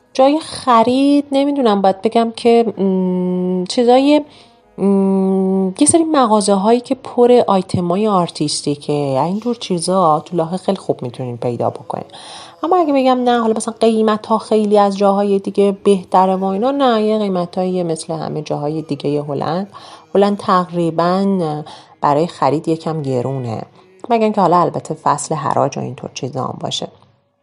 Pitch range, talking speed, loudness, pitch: 165-225 Hz, 150 wpm, -16 LUFS, 190 Hz